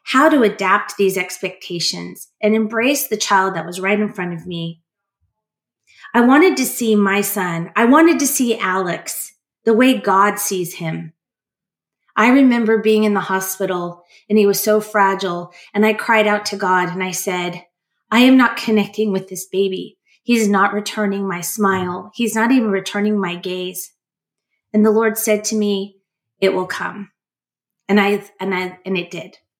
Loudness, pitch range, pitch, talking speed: -17 LUFS, 185-220 Hz, 200 Hz, 175 wpm